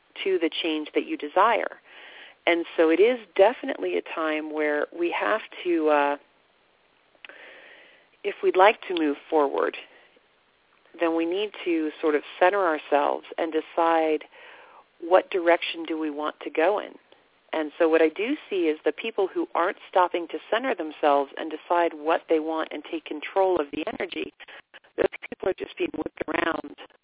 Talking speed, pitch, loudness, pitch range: 165 wpm, 165 Hz, -25 LUFS, 155-200 Hz